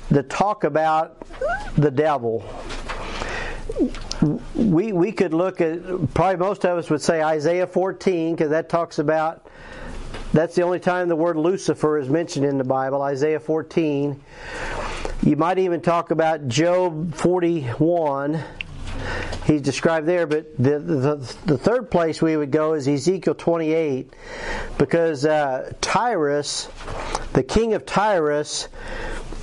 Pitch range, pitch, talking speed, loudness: 150-175 Hz, 160 Hz, 135 wpm, -22 LUFS